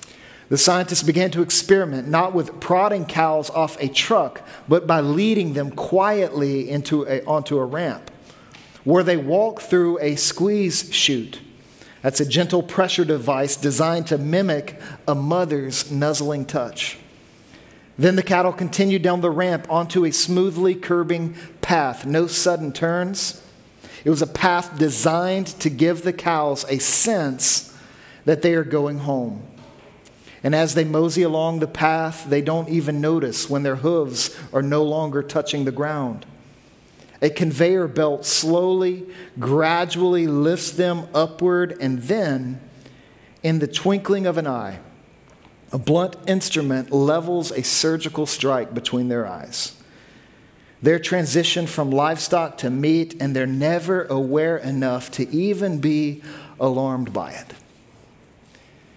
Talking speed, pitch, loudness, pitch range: 135 wpm, 160 Hz, -20 LUFS, 140-175 Hz